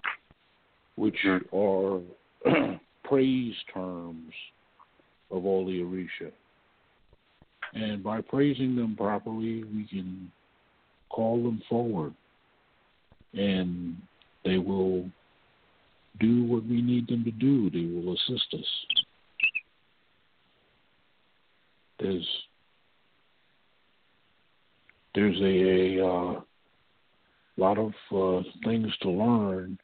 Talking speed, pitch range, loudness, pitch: 85 wpm, 95-115 Hz, -28 LUFS, 100 Hz